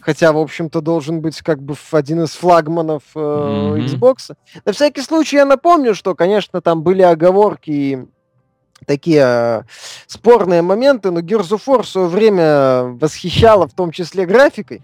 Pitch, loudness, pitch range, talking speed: 170 Hz, -14 LUFS, 155-210 Hz, 160 wpm